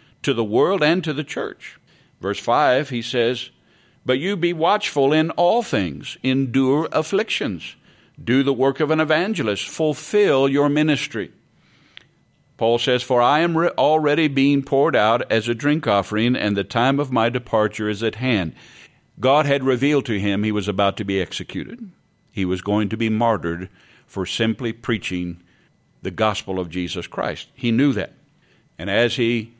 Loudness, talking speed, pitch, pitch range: -20 LUFS, 170 wpm, 125 Hz, 105-145 Hz